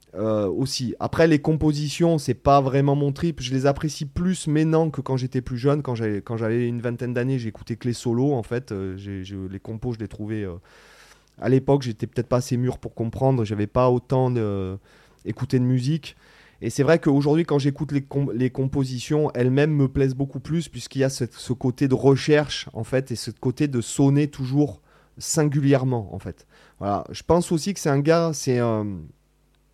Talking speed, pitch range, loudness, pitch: 210 wpm, 115-145 Hz, -23 LUFS, 130 Hz